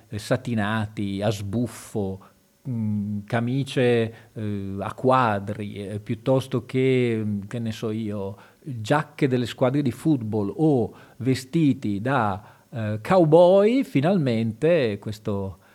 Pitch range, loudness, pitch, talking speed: 105-130 Hz, -24 LUFS, 115 Hz, 90 wpm